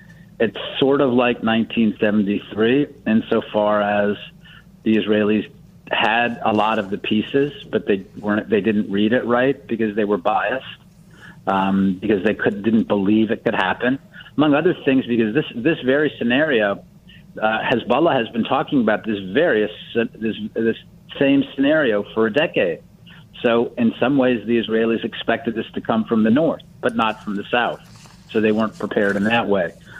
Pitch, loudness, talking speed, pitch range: 115 Hz, -19 LUFS, 165 wpm, 105-135 Hz